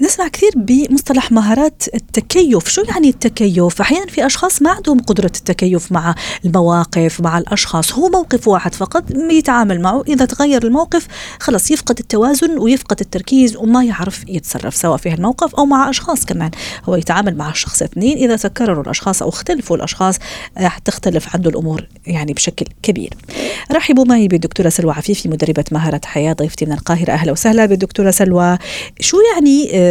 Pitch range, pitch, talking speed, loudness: 170-275 Hz, 205 Hz, 155 wpm, -14 LUFS